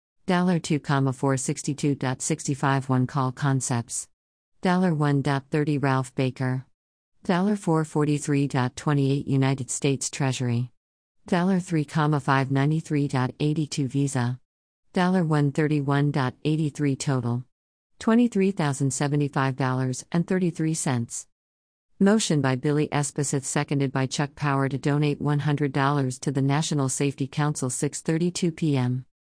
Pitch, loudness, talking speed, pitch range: 145 Hz, -25 LUFS, 70 wpm, 130-155 Hz